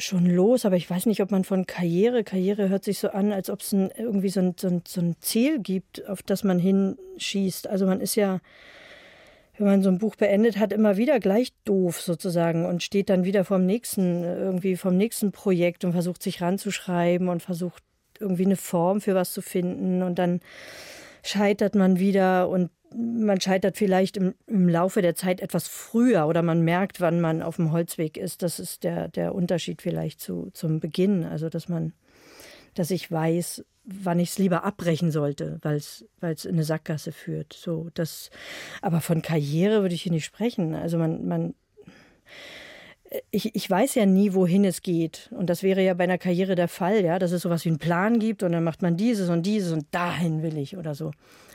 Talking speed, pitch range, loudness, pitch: 205 wpm, 170-200 Hz, -25 LUFS, 185 Hz